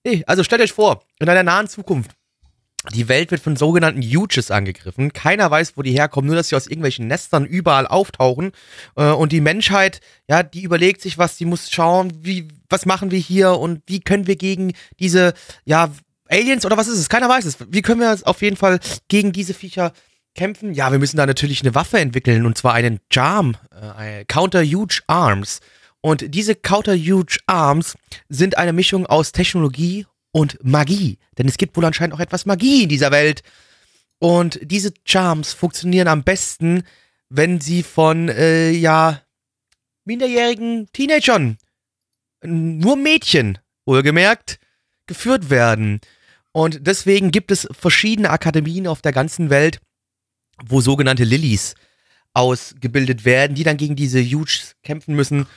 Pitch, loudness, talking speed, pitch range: 165 Hz, -16 LUFS, 160 wpm, 140-190 Hz